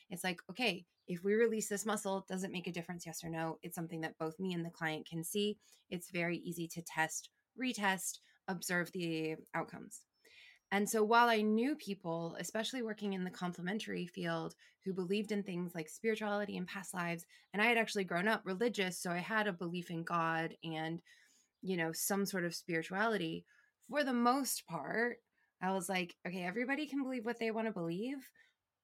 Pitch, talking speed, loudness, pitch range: 190 Hz, 195 wpm, -38 LUFS, 170-220 Hz